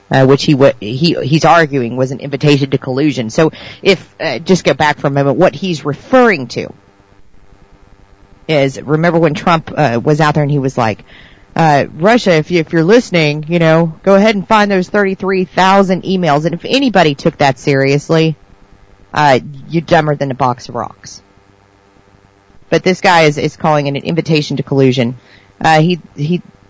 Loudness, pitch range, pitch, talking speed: -12 LUFS, 130-170 Hz, 150 Hz, 185 wpm